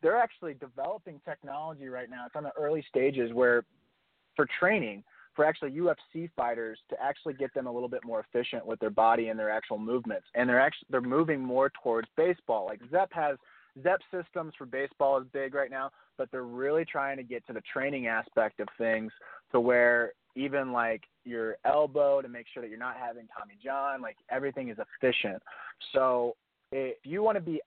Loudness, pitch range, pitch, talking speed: -31 LUFS, 120-150 Hz, 135 Hz, 195 wpm